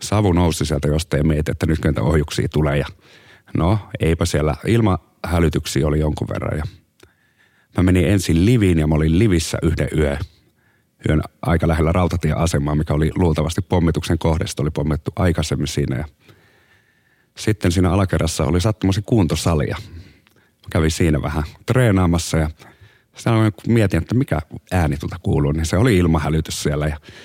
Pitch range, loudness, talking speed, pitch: 75-100 Hz, -19 LUFS, 150 wpm, 85 Hz